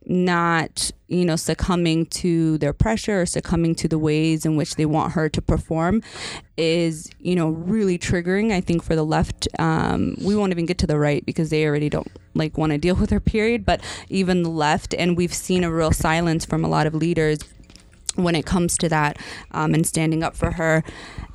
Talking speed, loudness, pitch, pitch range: 210 wpm, -21 LUFS, 165 Hz, 155-175 Hz